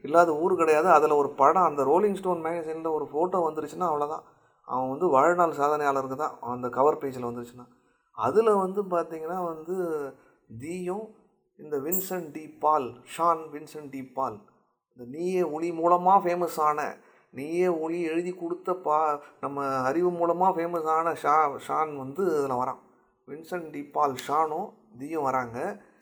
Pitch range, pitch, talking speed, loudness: 145-175 Hz, 160 Hz, 135 wpm, -26 LUFS